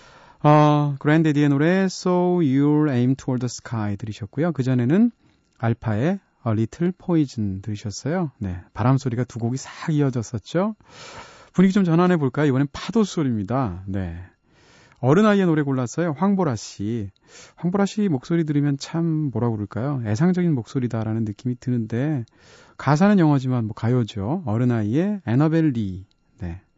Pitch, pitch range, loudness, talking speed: 140 Hz, 115-170 Hz, -22 LUFS, 375 characters per minute